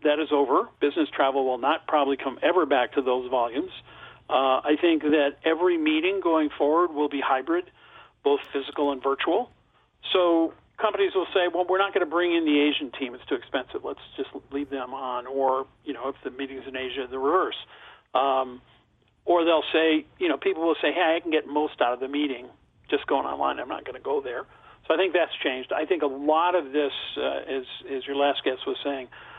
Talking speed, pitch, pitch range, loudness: 220 wpm, 145 Hz, 135-170 Hz, -25 LUFS